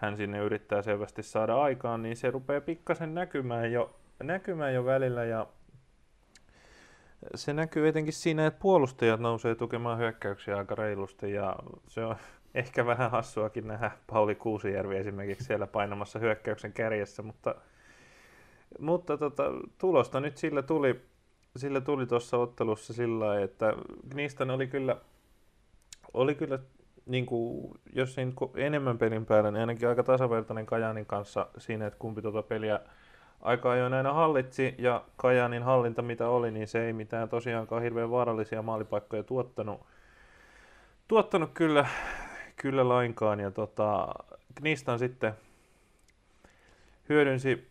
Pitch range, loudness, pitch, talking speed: 110-135 Hz, -31 LUFS, 120 Hz, 130 wpm